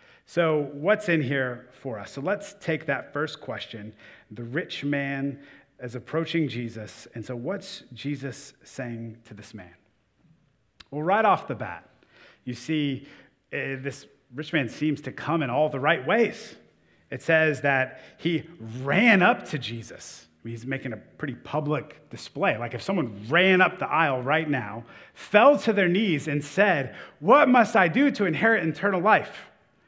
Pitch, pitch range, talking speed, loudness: 145 Hz, 125-170 Hz, 165 wpm, -24 LUFS